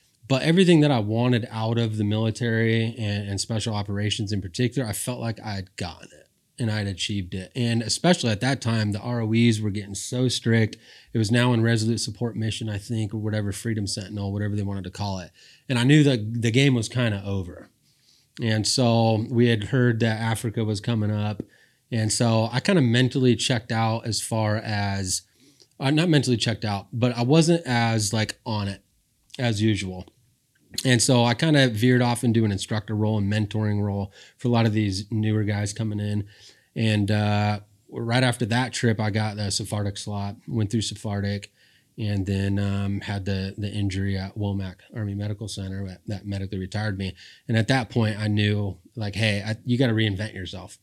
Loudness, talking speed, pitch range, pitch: -24 LUFS, 200 wpm, 105-120 Hz, 110 Hz